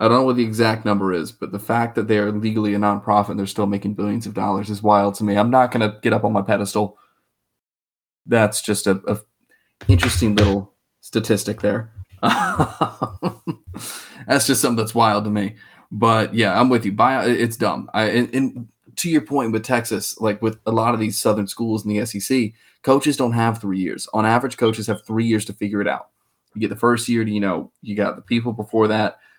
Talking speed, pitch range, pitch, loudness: 220 wpm, 105-115 Hz, 110 Hz, -20 LUFS